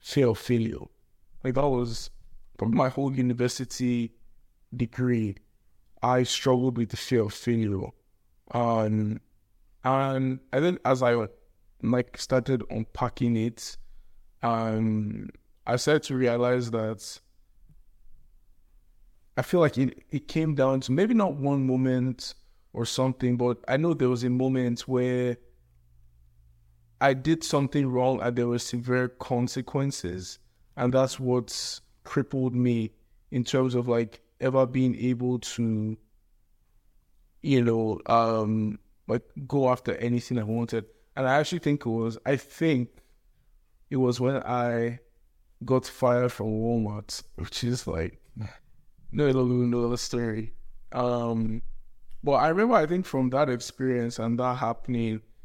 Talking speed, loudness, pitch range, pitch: 135 wpm, -27 LUFS, 110-130 Hz, 120 Hz